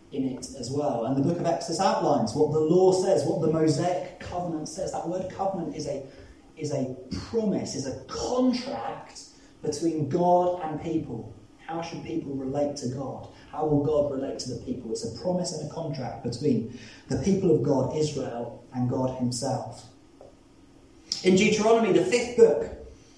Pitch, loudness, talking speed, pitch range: 155 Hz, -27 LUFS, 175 wpm, 135-180 Hz